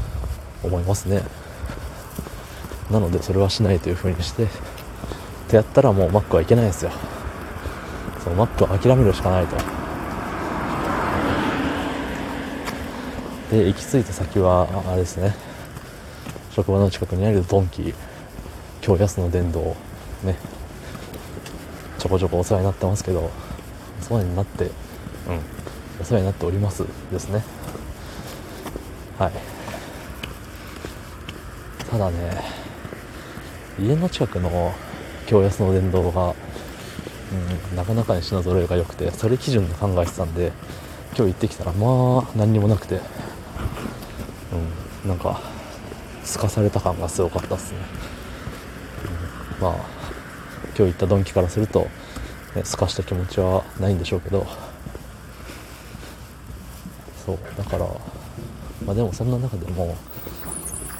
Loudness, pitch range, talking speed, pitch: -23 LUFS, 90-105 Hz, 250 characters per minute, 95 Hz